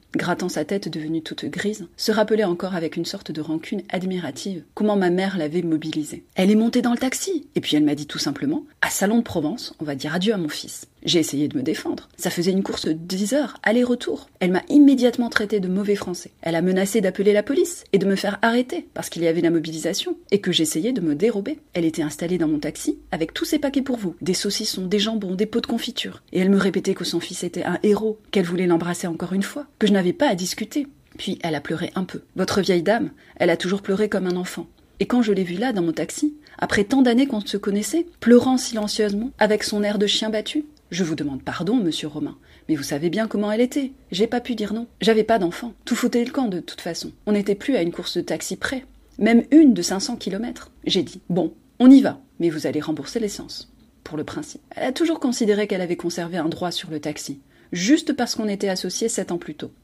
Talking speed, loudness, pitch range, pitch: 245 wpm, -22 LUFS, 175-235 Hz, 200 Hz